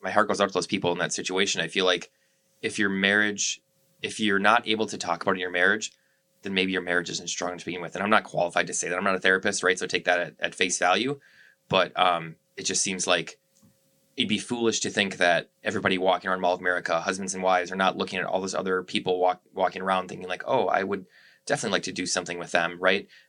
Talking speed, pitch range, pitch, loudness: 260 wpm, 90-100 Hz, 95 Hz, -25 LUFS